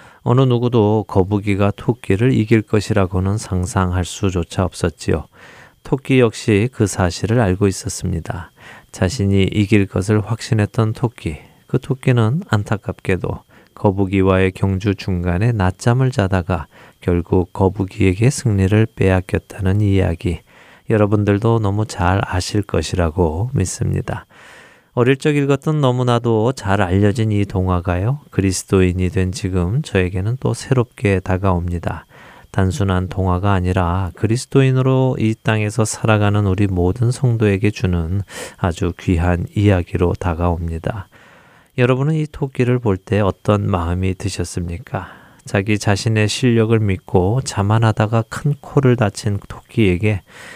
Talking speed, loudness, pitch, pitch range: 295 characters per minute, -18 LUFS, 100 Hz, 95-115 Hz